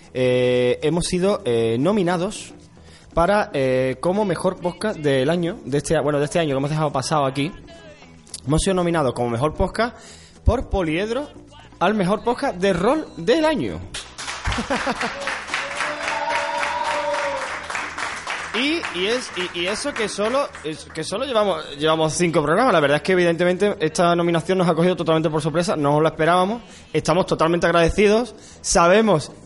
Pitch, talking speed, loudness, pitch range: 175 Hz, 145 wpm, -21 LUFS, 155-205 Hz